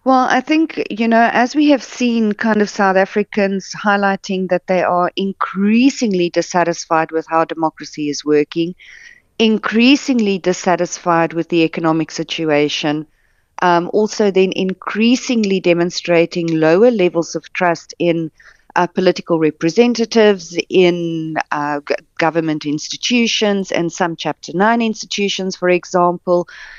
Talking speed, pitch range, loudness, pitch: 120 wpm, 165-215 Hz, -16 LUFS, 180 Hz